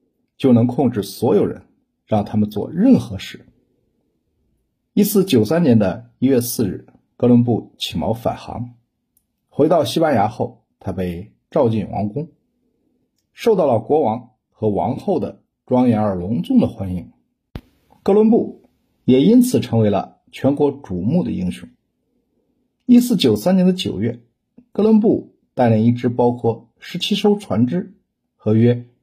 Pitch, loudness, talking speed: 120 Hz, -18 LUFS, 205 characters per minute